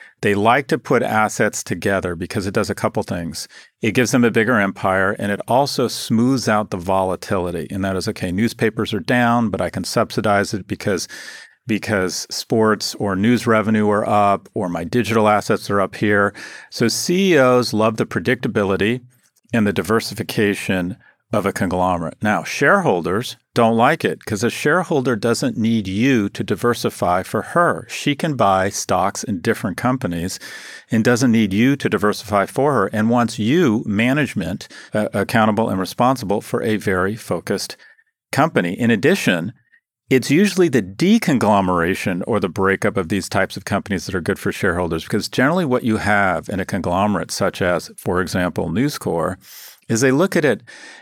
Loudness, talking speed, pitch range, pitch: -19 LUFS, 170 wpm, 100-120 Hz, 110 Hz